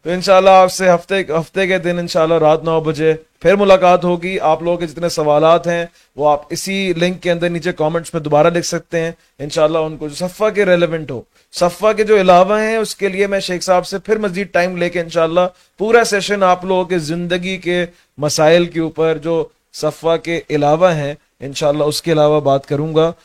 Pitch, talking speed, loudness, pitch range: 175 Hz, 215 wpm, -15 LUFS, 160-185 Hz